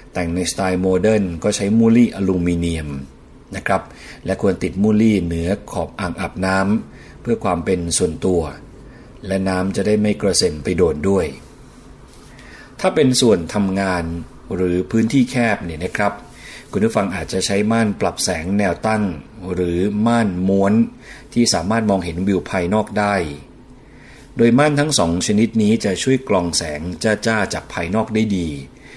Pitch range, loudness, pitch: 90-110 Hz, -18 LUFS, 95 Hz